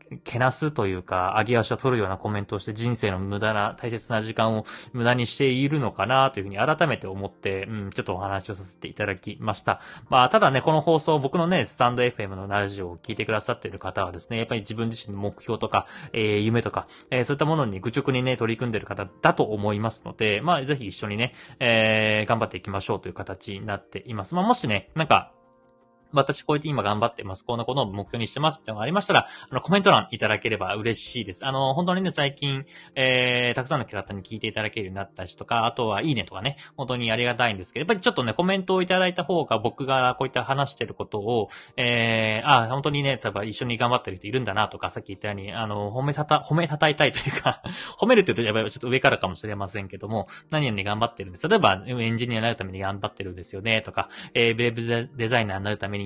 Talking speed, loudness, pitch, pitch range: 515 characters per minute, -25 LUFS, 115 Hz, 105-135 Hz